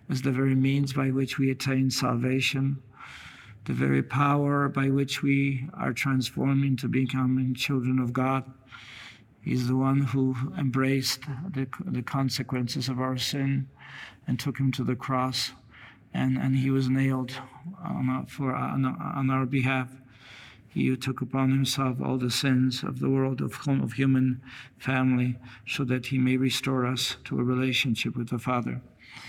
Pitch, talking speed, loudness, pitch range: 130 Hz, 160 wpm, -27 LUFS, 125-135 Hz